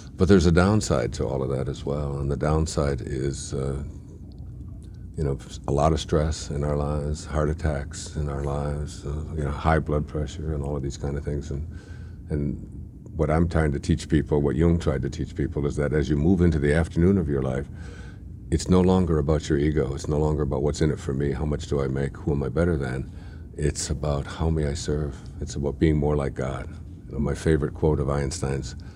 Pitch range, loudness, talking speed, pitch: 70-85 Hz, -25 LUFS, 230 wpm, 75 Hz